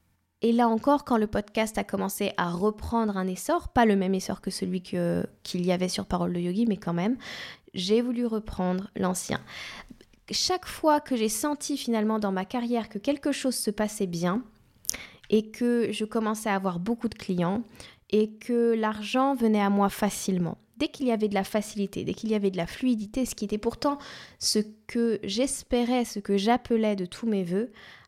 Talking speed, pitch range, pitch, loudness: 195 wpm, 195-235 Hz, 215 Hz, -27 LUFS